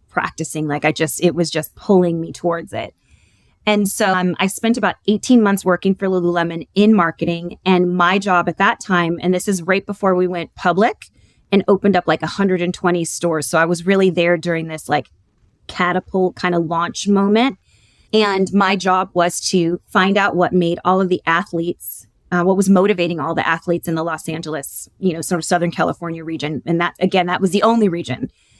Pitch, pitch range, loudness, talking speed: 175 Hz, 165-190 Hz, -17 LUFS, 200 wpm